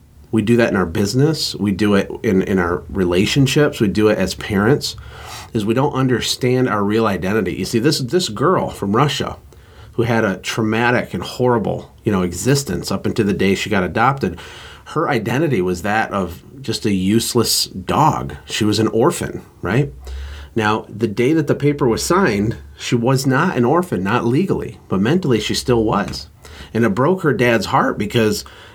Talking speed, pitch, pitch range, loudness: 185 wpm, 115 Hz, 100-130 Hz, -17 LUFS